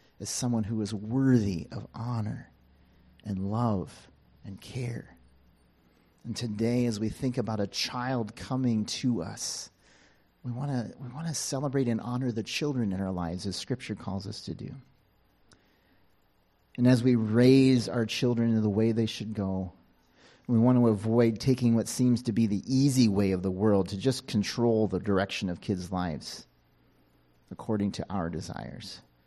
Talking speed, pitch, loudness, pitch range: 160 wpm, 110 Hz, -28 LUFS, 95-125 Hz